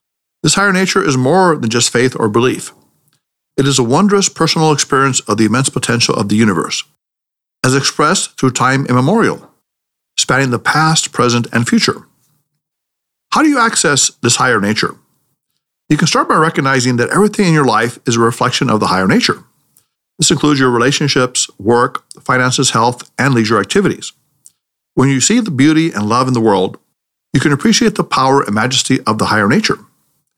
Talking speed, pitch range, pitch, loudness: 175 wpm, 120-160 Hz, 135 Hz, -12 LUFS